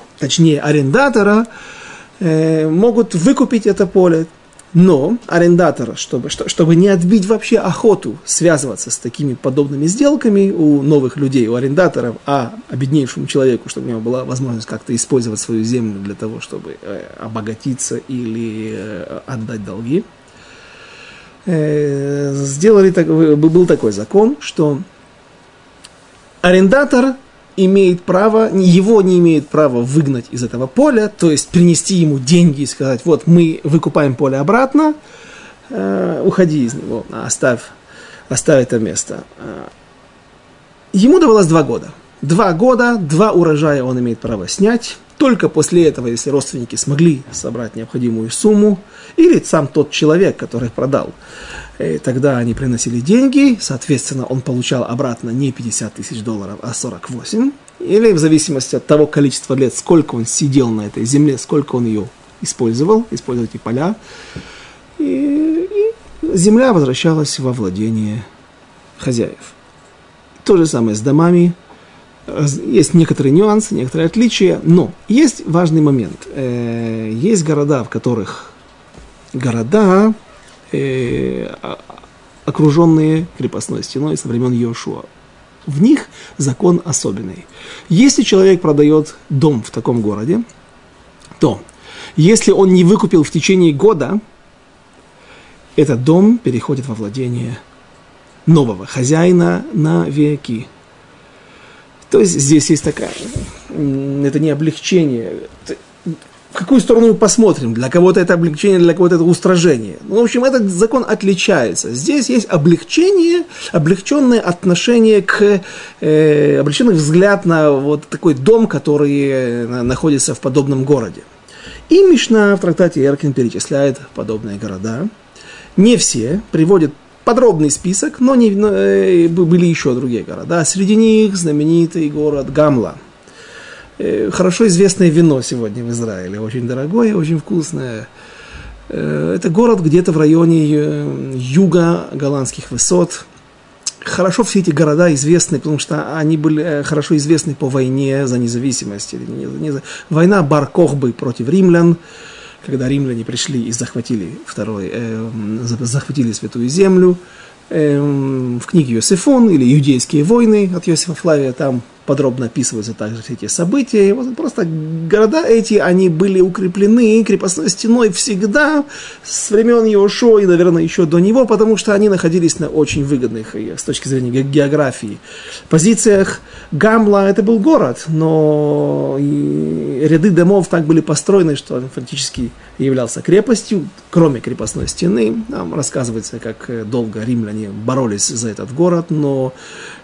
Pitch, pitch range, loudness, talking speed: 155 Hz, 130-190 Hz, -13 LUFS, 125 wpm